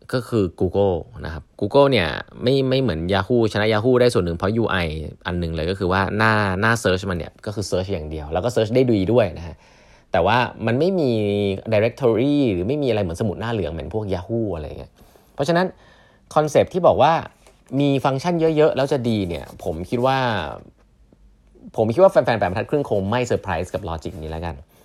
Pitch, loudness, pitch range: 105 Hz, -20 LUFS, 90-125 Hz